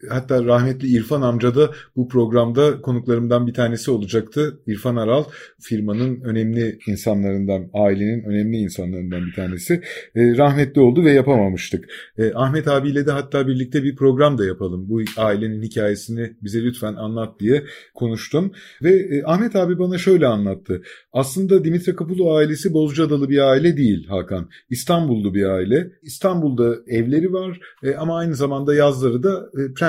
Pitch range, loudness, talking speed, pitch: 110-150 Hz, -19 LUFS, 145 wpm, 125 Hz